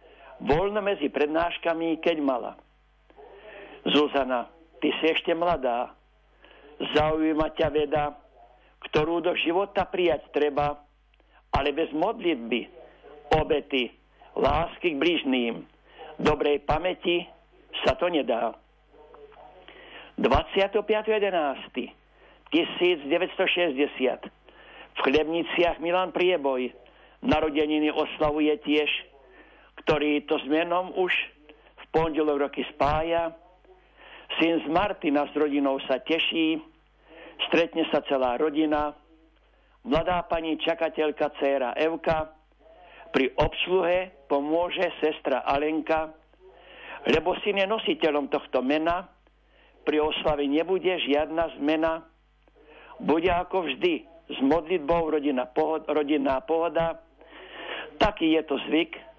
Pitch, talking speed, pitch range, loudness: 160 Hz, 90 wpm, 150-175 Hz, -26 LUFS